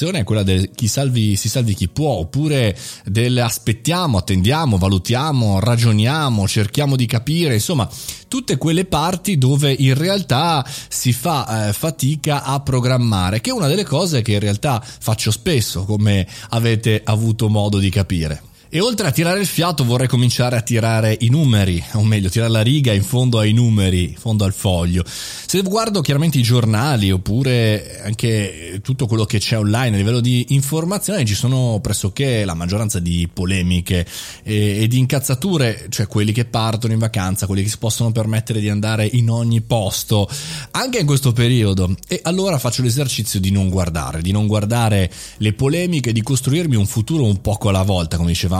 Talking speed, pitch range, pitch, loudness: 175 wpm, 105-135 Hz, 115 Hz, -17 LUFS